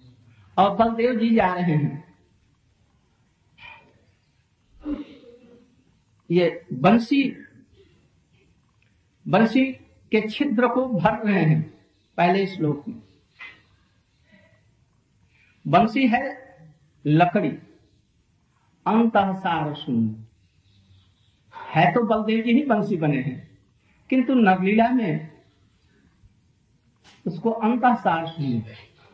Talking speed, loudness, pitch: 80 wpm, -22 LUFS, 160 Hz